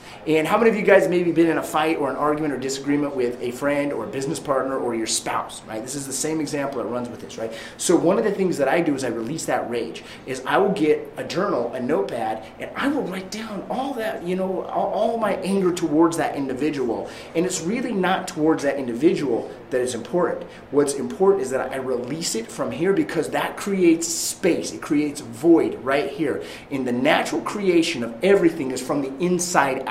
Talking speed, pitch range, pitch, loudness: 230 wpm, 135-185 Hz, 155 Hz, -22 LUFS